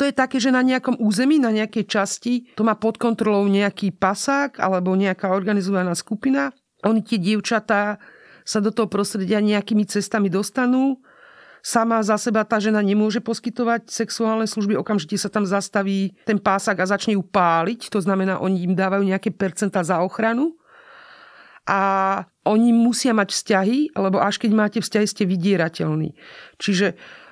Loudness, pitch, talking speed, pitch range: -20 LUFS, 210 Hz, 155 wpm, 195-230 Hz